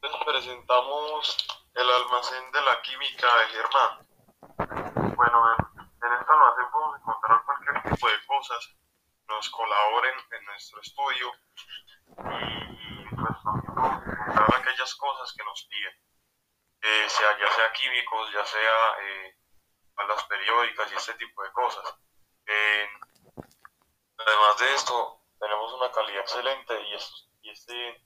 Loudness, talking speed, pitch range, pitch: -25 LUFS, 130 wpm, 105-125 Hz, 115 Hz